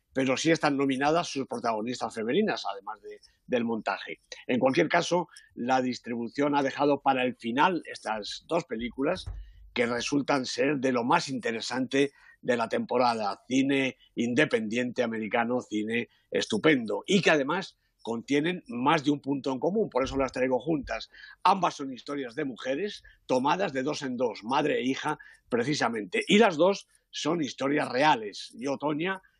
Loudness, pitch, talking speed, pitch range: -28 LUFS, 135 Hz, 155 wpm, 120-155 Hz